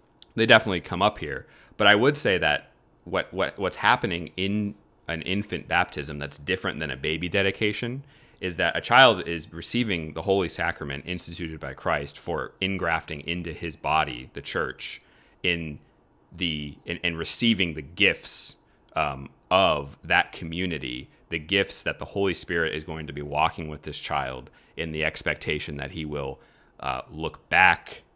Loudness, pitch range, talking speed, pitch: -25 LUFS, 75-95 Hz, 160 wpm, 85 Hz